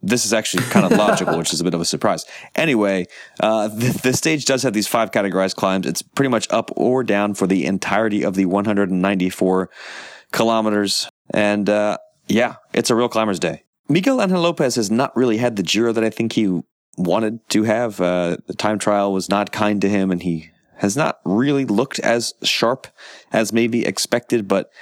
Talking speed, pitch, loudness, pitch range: 200 wpm, 105 Hz, -19 LUFS, 95-115 Hz